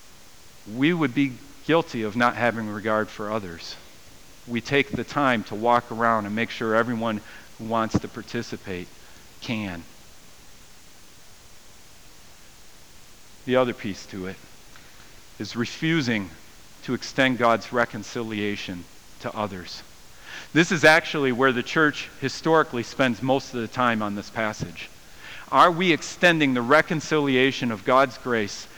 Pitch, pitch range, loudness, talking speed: 120 Hz, 105-135 Hz, -23 LUFS, 130 wpm